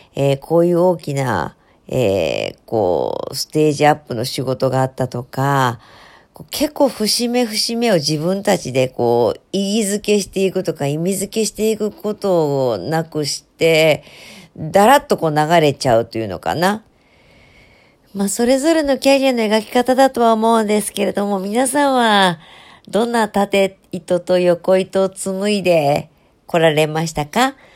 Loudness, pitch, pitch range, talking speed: -17 LUFS, 190 Hz, 150-215 Hz, 290 characters per minute